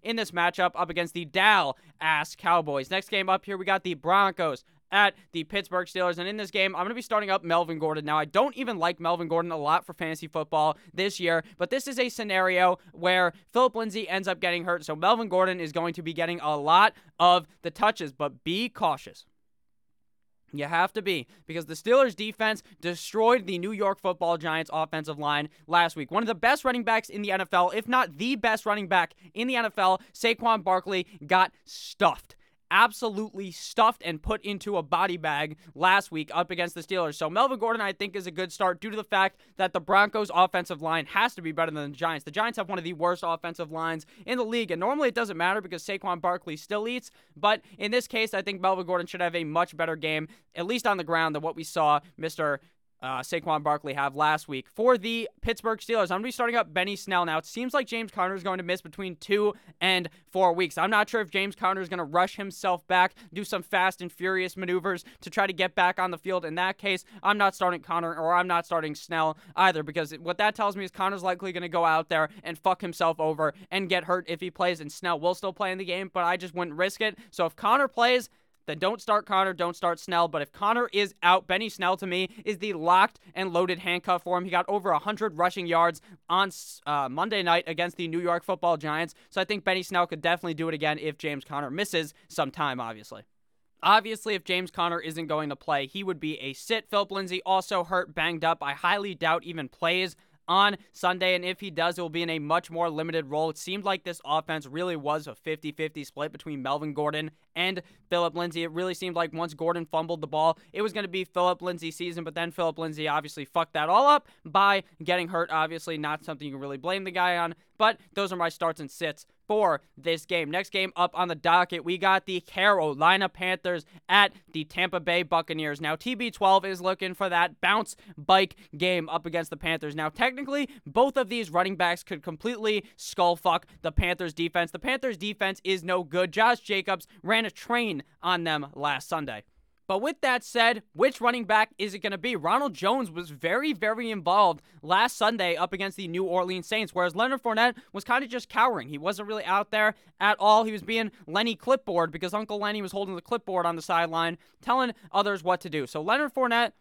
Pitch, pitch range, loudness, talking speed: 180 Hz, 165-200 Hz, -27 LUFS, 225 wpm